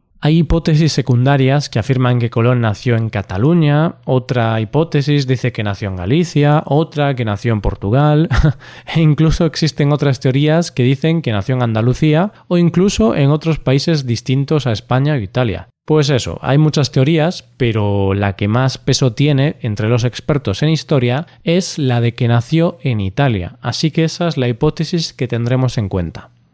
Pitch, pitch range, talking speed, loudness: 135 Hz, 120-155 Hz, 175 wpm, -15 LUFS